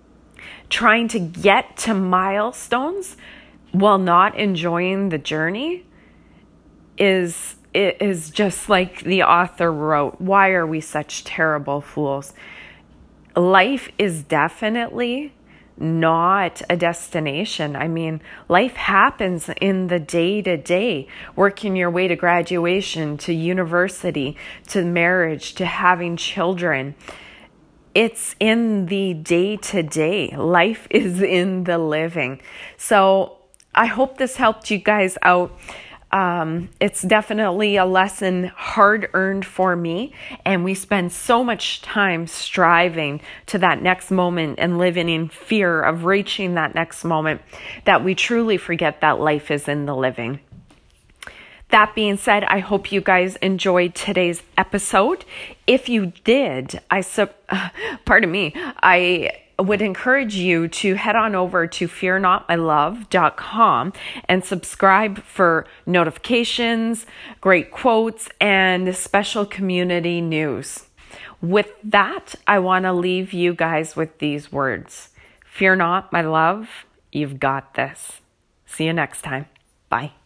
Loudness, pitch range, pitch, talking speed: -19 LUFS, 165-200 Hz, 185 Hz, 125 wpm